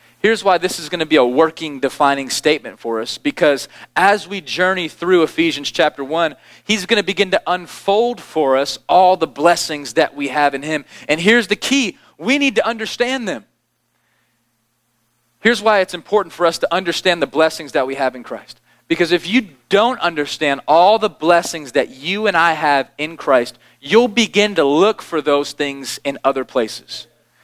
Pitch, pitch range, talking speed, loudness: 165 Hz, 140-200 Hz, 190 wpm, -16 LUFS